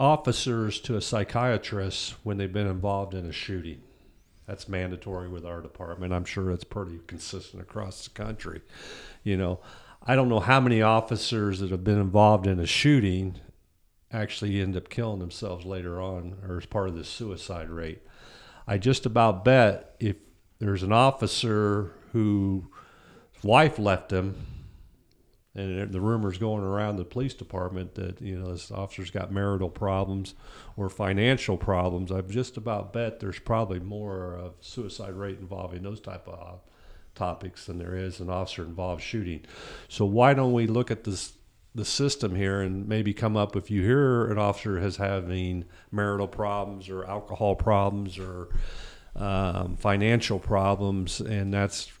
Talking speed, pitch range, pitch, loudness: 165 wpm, 90-110 Hz, 100 Hz, -27 LUFS